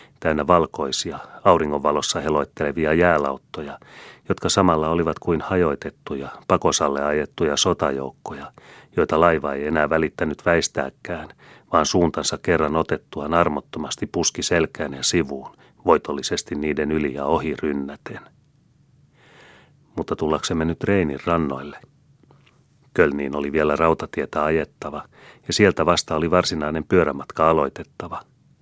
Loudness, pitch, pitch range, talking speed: -21 LUFS, 75 Hz, 75-85 Hz, 105 wpm